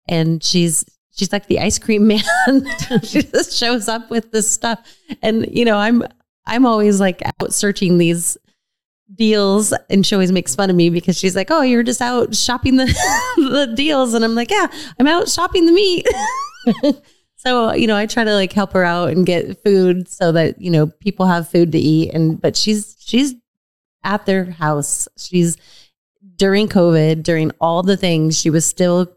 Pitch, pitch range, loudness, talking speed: 205 Hz, 175-245 Hz, -15 LUFS, 190 wpm